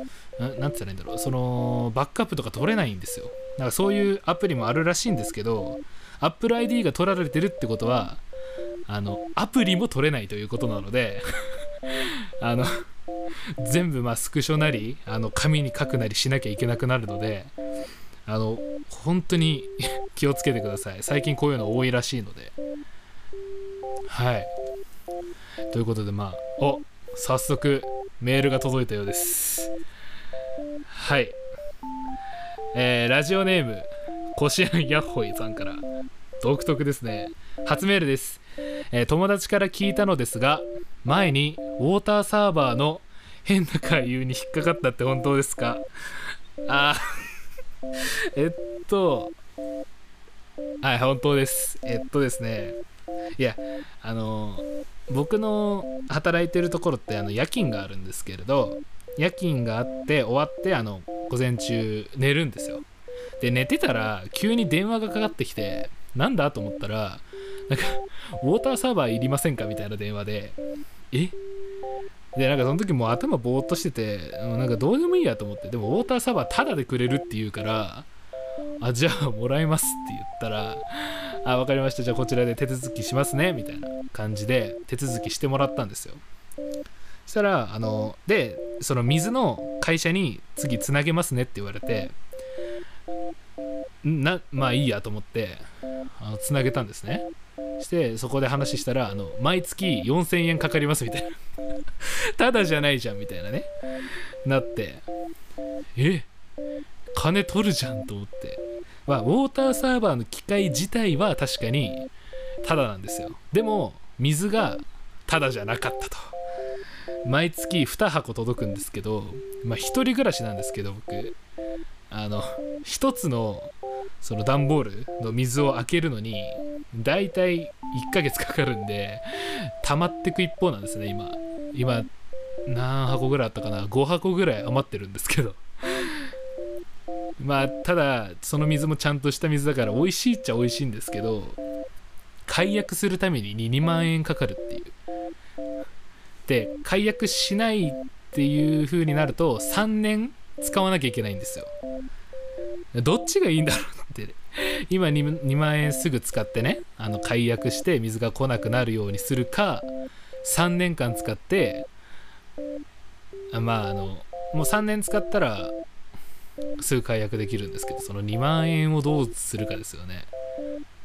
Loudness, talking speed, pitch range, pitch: -26 LUFS, 300 characters per minute, 115-175 Hz, 135 Hz